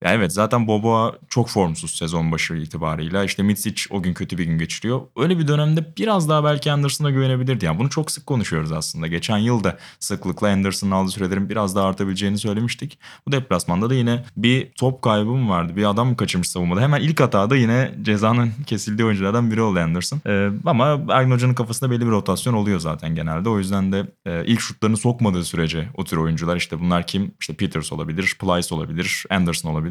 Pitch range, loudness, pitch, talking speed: 90-125 Hz, -20 LUFS, 105 Hz, 200 wpm